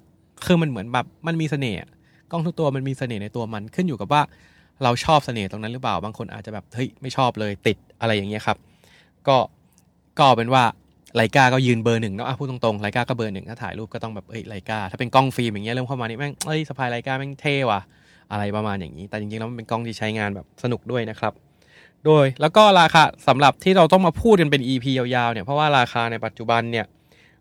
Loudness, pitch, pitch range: -21 LUFS, 120 Hz, 110-140 Hz